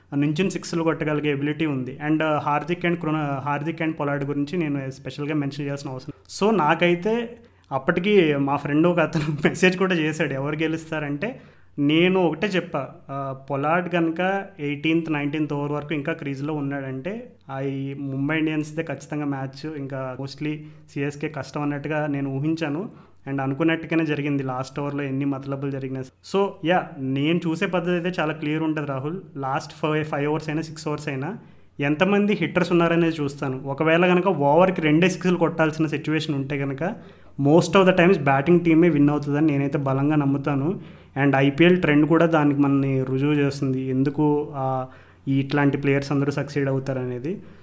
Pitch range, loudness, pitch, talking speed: 140-165 Hz, -23 LUFS, 150 Hz, 150 wpm